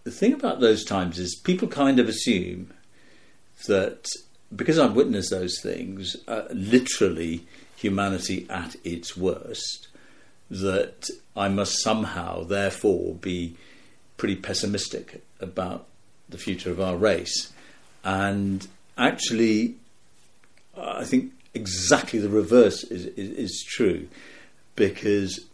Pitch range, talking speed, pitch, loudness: 95-110 Hz, 115 wpm, 100 Hz, -25 LUFS